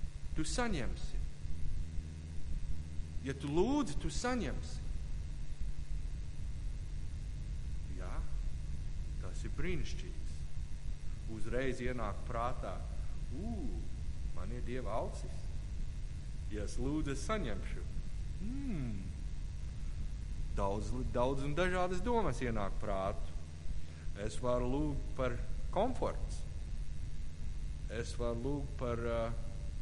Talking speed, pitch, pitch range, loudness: 75 wpm, 80 Hz, 75-115 Hz, -41 LUFS